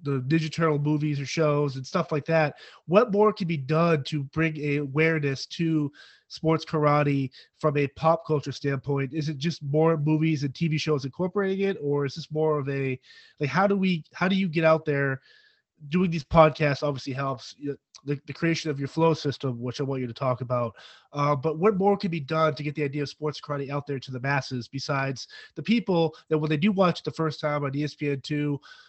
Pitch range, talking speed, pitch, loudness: 140-160 Hz, 220 wpm, 150 Hz, -26 LUFS